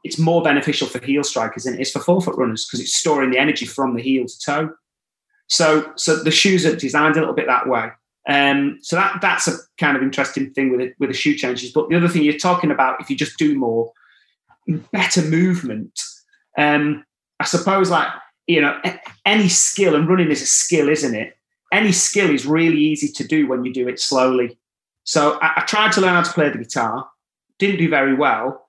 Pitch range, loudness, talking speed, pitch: 135-175 Hz, -17 LUFS, 220 wpm, 150 Hz